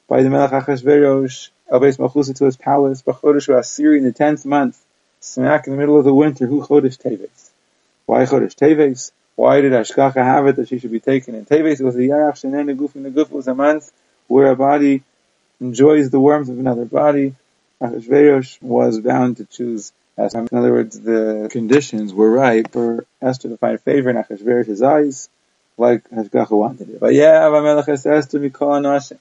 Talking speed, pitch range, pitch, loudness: 195 wpm, 120-145 Hz, 135 Hz, -15 LUFS